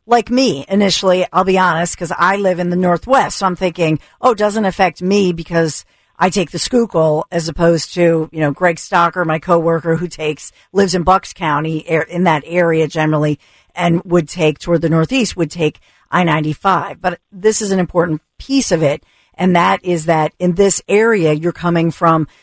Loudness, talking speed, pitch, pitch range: -15 LUFS, 195 wpm, 175 Hz, 160-185 Hz